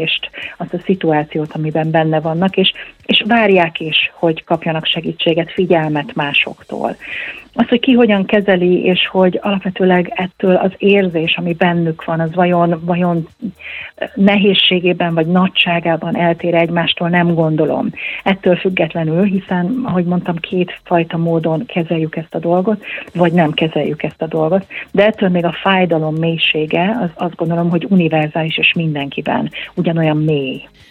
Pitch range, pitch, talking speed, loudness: 165-190 Hz, 175 Hz, 140 wpm, -15 LUFS